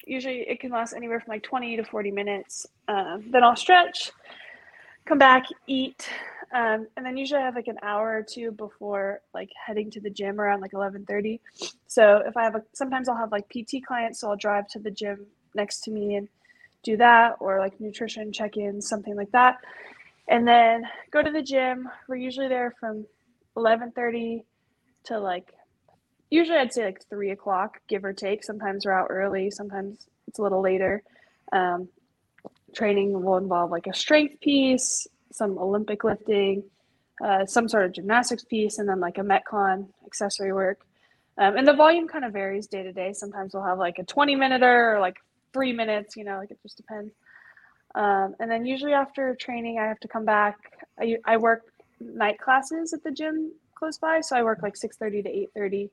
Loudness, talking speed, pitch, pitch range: -25 LUFS, 195 wpm, 220 Hz, 200-250 Hz